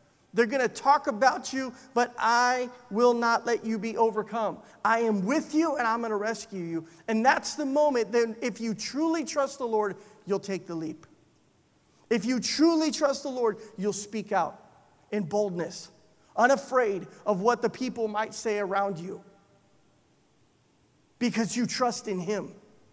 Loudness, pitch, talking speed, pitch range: -28 LUFS, 225 Hz, 170 wpm, 205-250 Hz